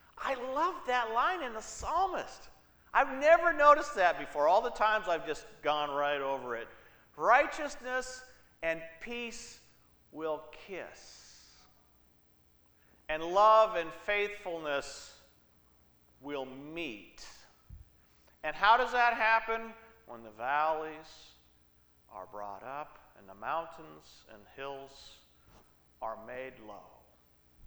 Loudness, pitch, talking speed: -31 LUFS, 145 Hz, 110 wpm